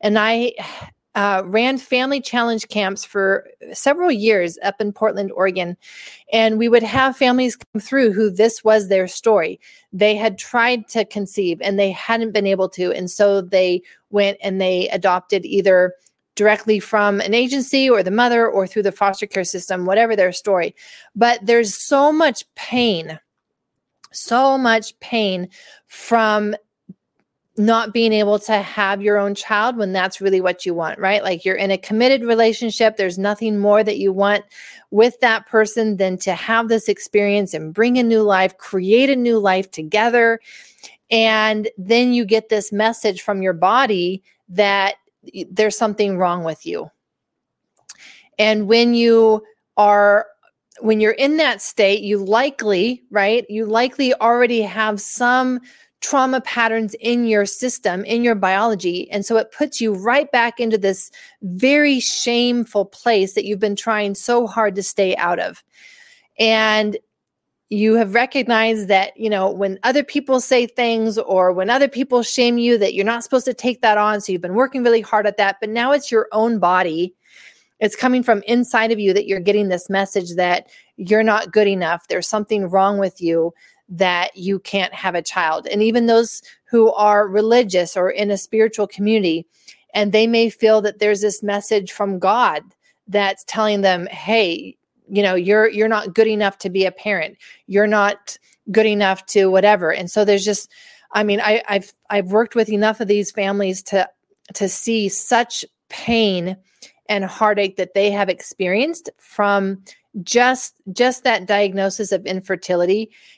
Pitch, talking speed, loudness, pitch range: 210 Hz, 170 wpm, -17 LUFS, 195-230 Hz